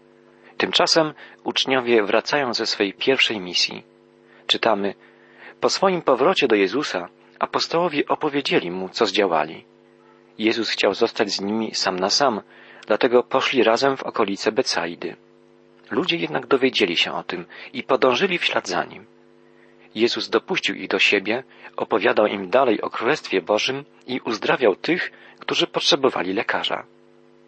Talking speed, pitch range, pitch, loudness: 135 wpm, 95-130 Hz, 115 Hz, -21 LUFS